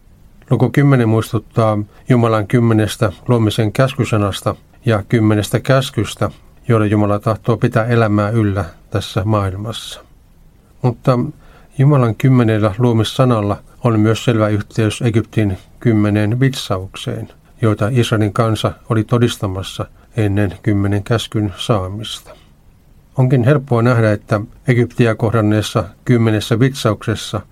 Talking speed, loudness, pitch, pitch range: 100 wpm, -16 LUFS, 110 Hz, 105-120 Hz